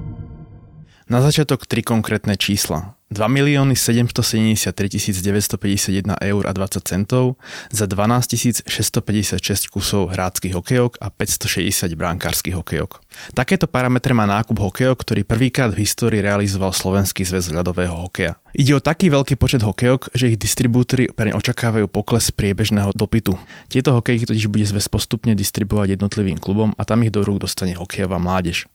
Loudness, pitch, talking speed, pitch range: -18 LUFS, 105 Hz, 140 wpm, 95-120 Hz